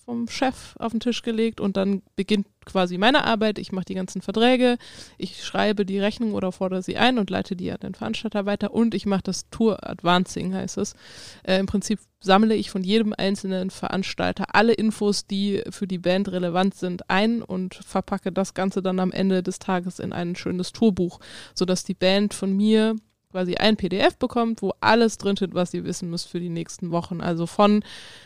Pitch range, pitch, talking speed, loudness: 185-215 Hz, 195 Hz, 200 wpm, -23 LUFS